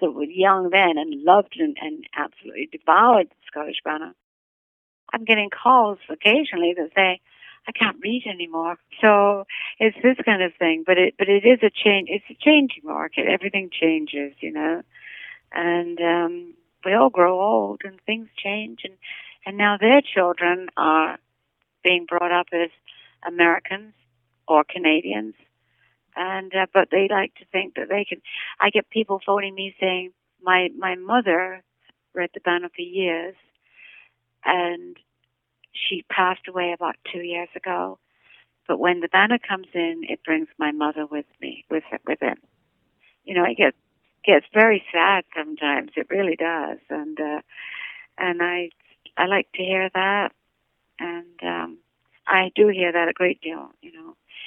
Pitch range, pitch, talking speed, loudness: 170-200 Hz, 180 Hz, 160 wpm, -21 LUFS